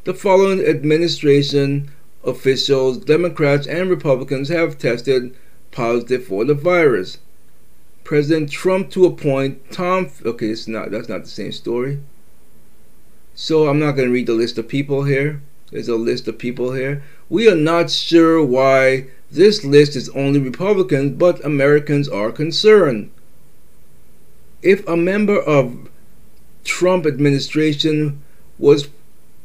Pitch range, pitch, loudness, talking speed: 130-160 Hz, 140 Hz, -16 LUFS, 130 wpm